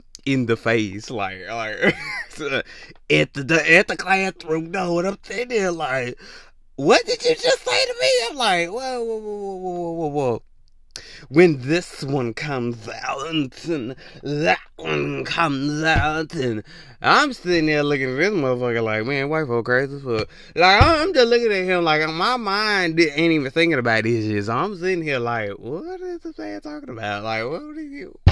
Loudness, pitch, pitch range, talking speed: -20 LUFS, 160 Hz, 120-195 Hz, 185 wpm